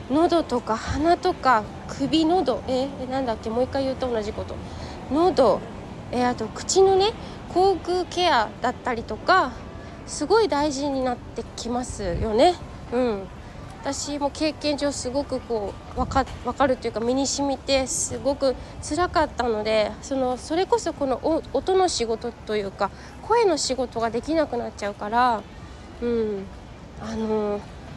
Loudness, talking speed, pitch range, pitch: -24 LUFS, 290 characters per minute, 235-310 Hz, 265 Hz